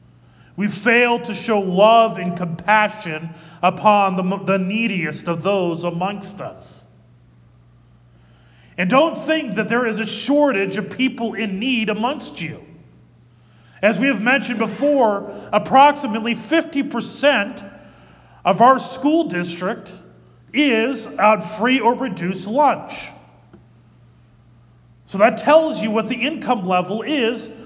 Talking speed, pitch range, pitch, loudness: 120 wpm, 175-240 Hz, 210 Hz, -18 LUFS